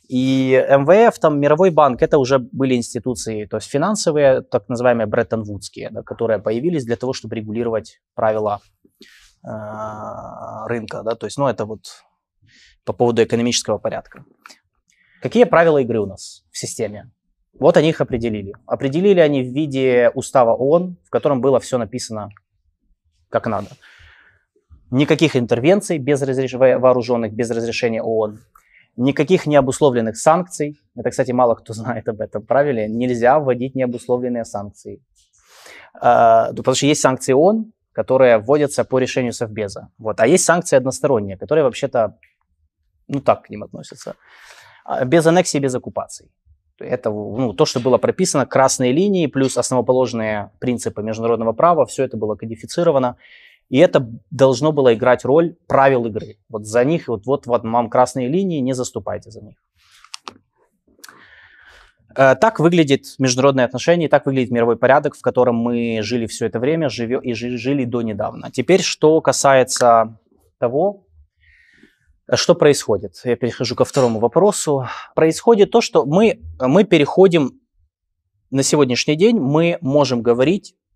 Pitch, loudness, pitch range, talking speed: 125 Hz, -17 LUFS, 115-145 Hz, 140 wpm